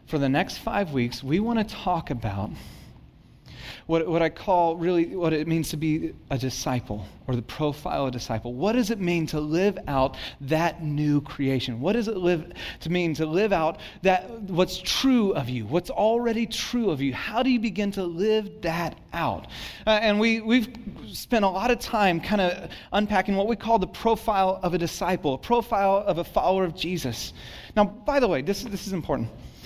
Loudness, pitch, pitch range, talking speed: -25 LUFS, 180 Hz, 150-210 Hz, 200 wpm